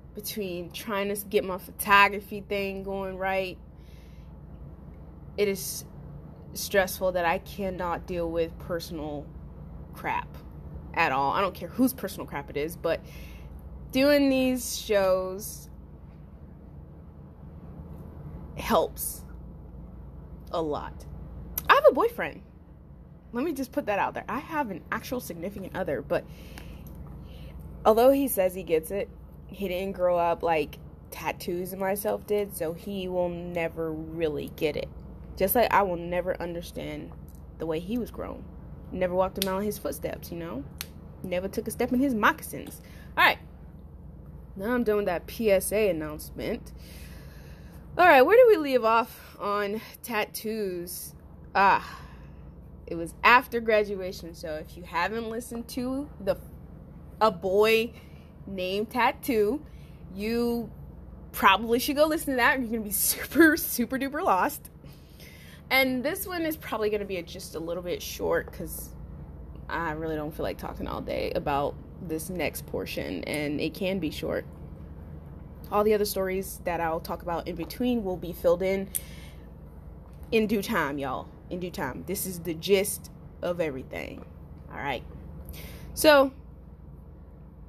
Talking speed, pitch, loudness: 145 wpm, 185 Hz, -27 LUFS